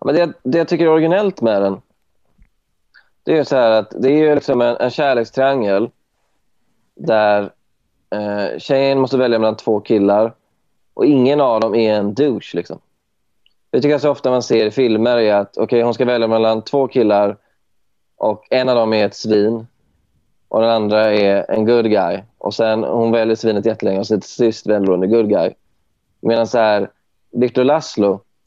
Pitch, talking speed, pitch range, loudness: 110 Hz, 175 wpm, 105-125 Hz, -16 LUFS